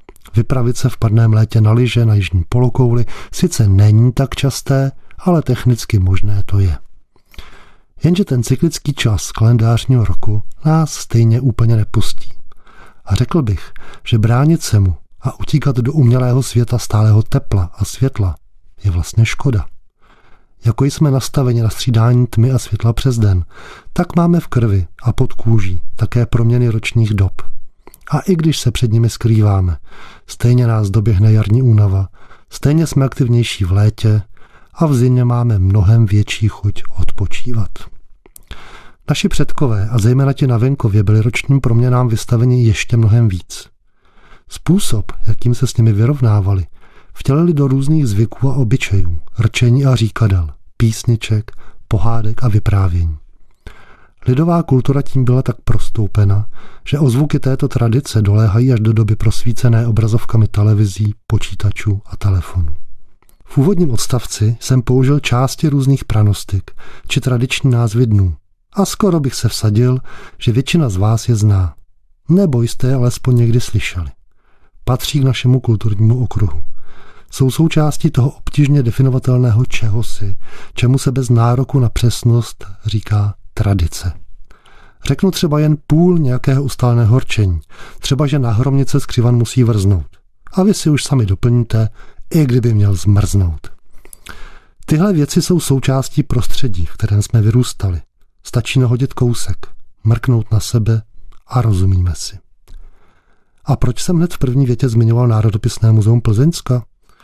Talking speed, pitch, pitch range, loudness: 140 wpm, 115 Hz, 105-130 Hz, -14 LUFS